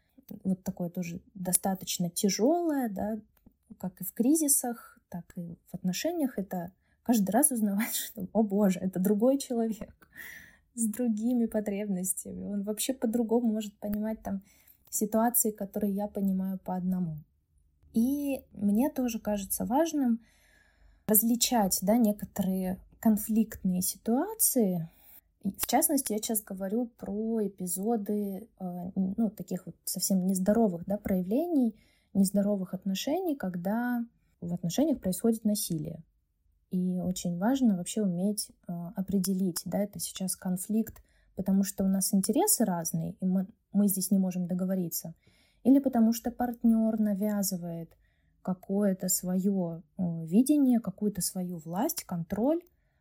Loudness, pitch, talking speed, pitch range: -29 LUFS, 205 Hz, 120 wpm, 185-230 Hz